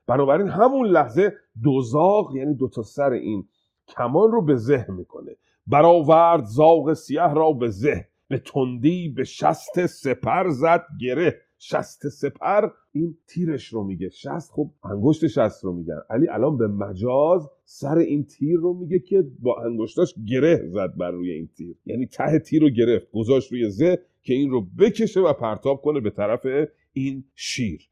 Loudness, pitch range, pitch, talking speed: -21 LUFS, 120-165 Hz, 145 Hz, 165 wpm